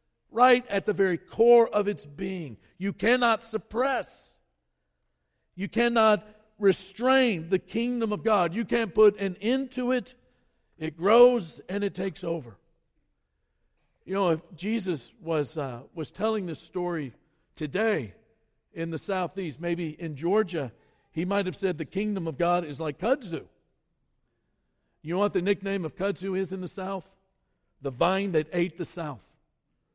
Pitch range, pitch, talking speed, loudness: 160-215 Hz, 185 Hz, 150 wpm, -27 LUFS